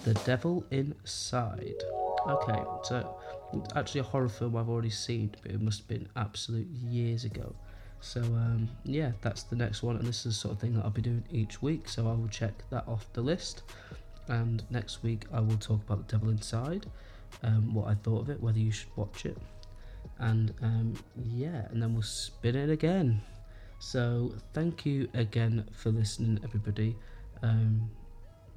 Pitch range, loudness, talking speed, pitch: 105-120 Hz, -33 LUFS, 180 wpm, 110 Hz